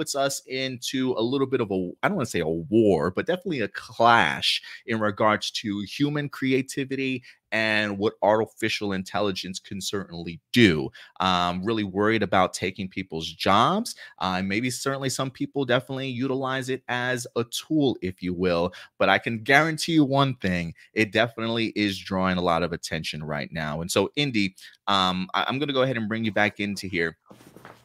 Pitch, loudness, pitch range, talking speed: 110 Hz, -25 LUFS, 95-130 Hz, 185 wpm